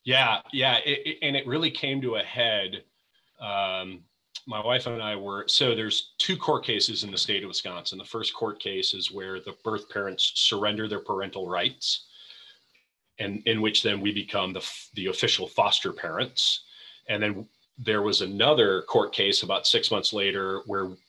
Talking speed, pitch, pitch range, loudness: 180 wpm, 105 Hz, 95-125 Hz, -25 LUFS